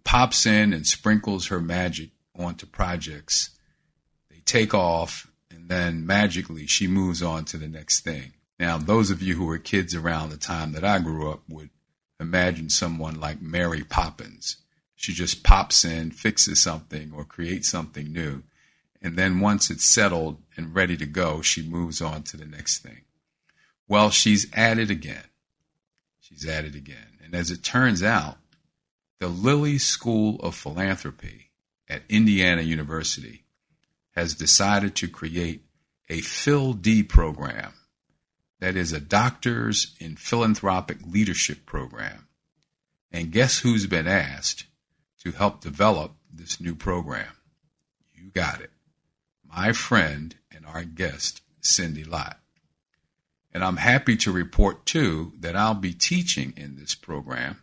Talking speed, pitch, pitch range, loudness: 145 wpm, 85 Hz, 80-95 Hz, -23 LUFS